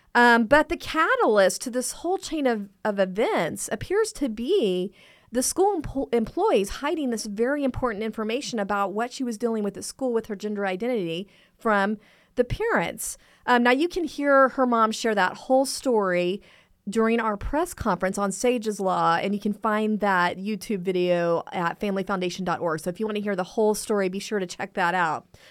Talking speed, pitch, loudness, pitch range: 190 wpm, 220 Hz, -24 LUFS, 195-255 Hz